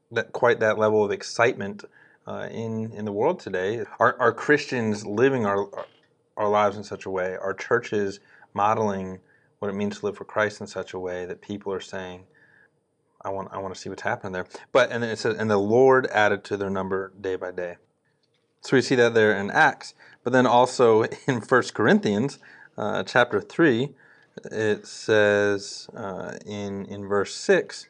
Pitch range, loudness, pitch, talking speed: 100-115 Hz, -24 LUFS, 105 Hz, 190 wpm